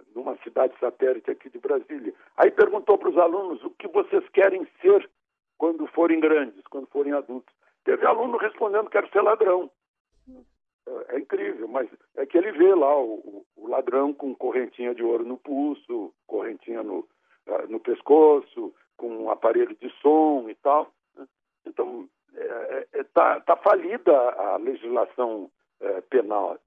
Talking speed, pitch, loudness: 150 wpm, 350 Hz, -23 LUFS